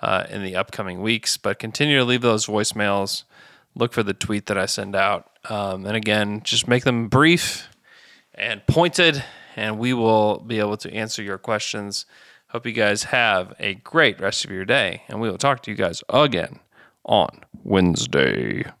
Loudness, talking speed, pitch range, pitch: -21 LUFS, 180 wpm, 105-120 Hz, 110 Hz